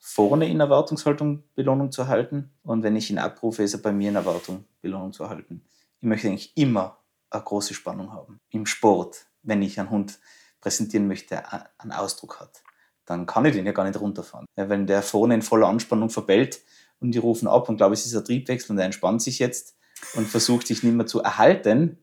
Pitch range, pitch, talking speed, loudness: 100-125 Hz, 110 Hz, 210 wpm, -23 LUFS